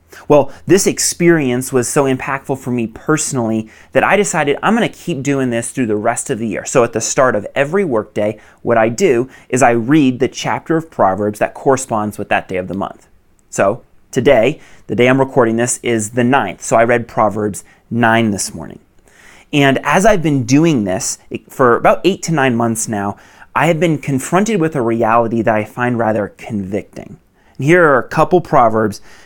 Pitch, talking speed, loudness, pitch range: 125 Hz, 200 wpm, -15 LUFS, 110-150 Hz